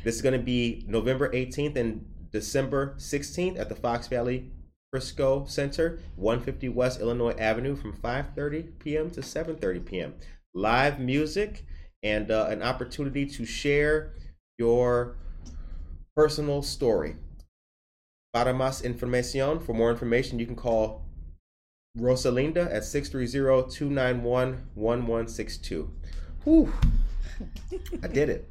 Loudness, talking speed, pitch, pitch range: -28 LUFS, 110 wpm, 120 Hz, 105-140 Hz